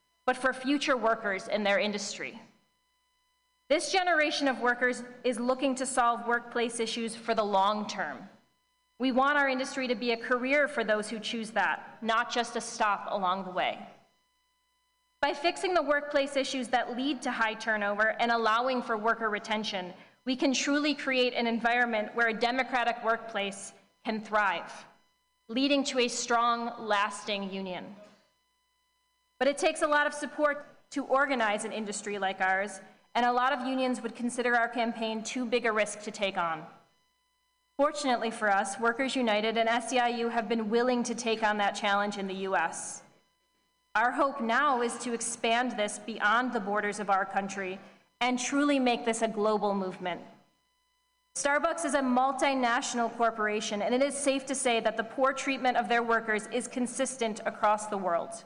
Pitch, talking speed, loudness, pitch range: 235 Hz, 170 wpm, -29 LUFS, 215-270 Hz